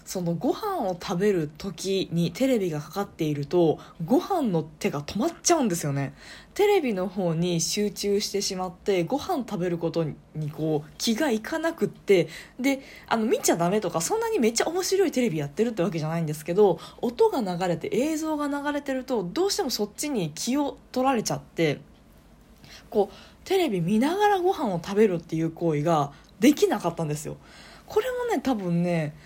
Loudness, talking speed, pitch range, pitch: -26 LUFS, 370 characters per minute, 170-285 Hz, 205 Hz